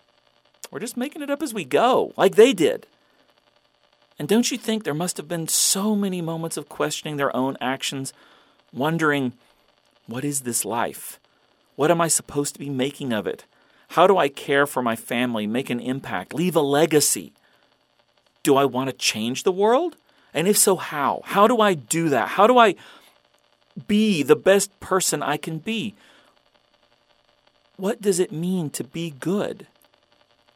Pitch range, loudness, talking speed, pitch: 135-200 Hz, -21 LUFS, 170 wpm, 160 Hz